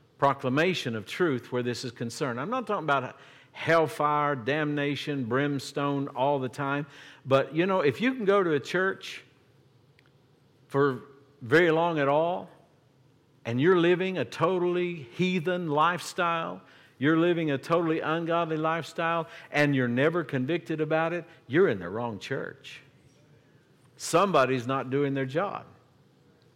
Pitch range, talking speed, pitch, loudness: 135-165 Hz, 140 wpm, 145 Hz, -27 LUFS